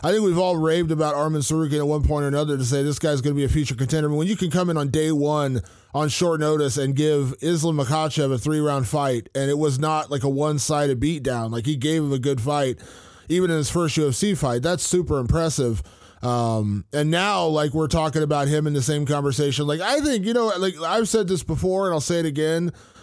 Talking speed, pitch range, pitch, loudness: 255 wpm, 140-165 Hz, 150 Hz, -22 LUFS